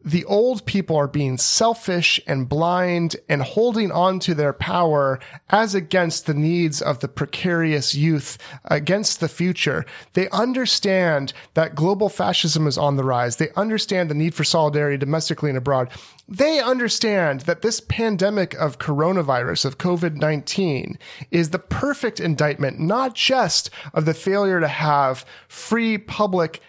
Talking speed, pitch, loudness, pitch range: 145 wpm, 170 Hz, -20 LUFS, 150-195 Hz